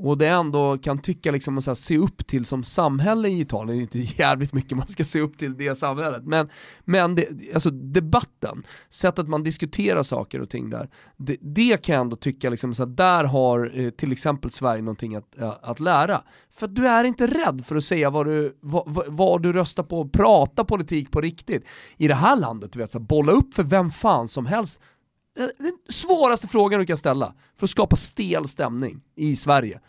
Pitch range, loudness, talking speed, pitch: 130-180 Hz, -22 LUFS, 205 wpm, 150 Hz